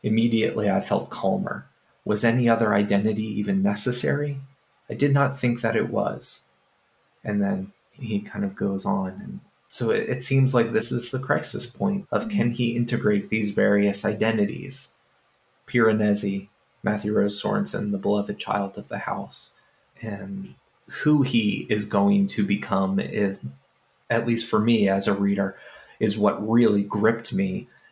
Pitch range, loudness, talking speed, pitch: 100-140 Hz, -24 LUFS, 155 wpm, 115 Hz